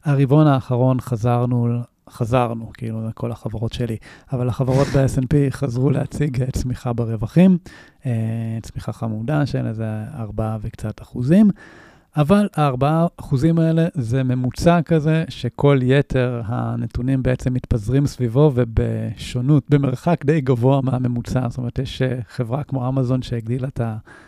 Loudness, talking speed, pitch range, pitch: -20 LUFS, 120 wpm, 120-140 Hz, 130 Hz